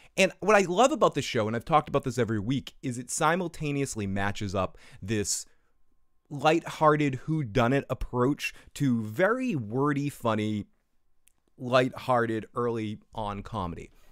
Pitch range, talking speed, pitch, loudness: 110-150 Hz, 130 wpm, 125 Hz, -28 LUFS